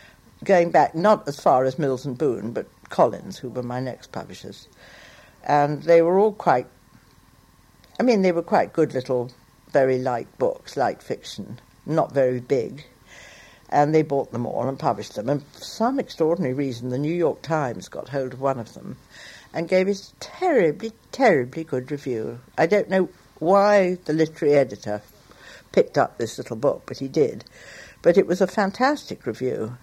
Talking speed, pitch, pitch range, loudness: 175 wpm, 155 Hz, 130-190 Hz, -22 LUFS